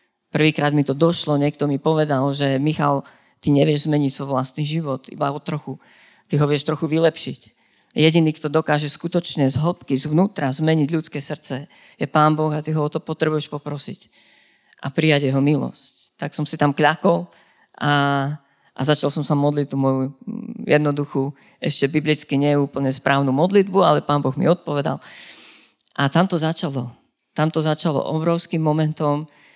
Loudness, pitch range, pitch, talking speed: -20 LUFS, 140-160 Hz, 150 Hz, 160 wpm